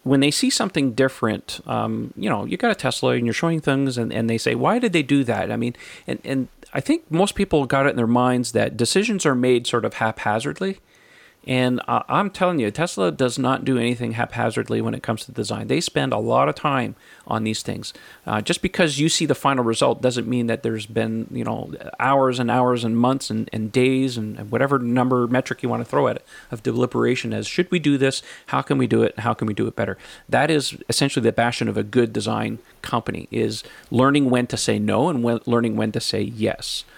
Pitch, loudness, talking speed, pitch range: 125 Hz, -21 LUFS, 235 wpm, 115-140 Hz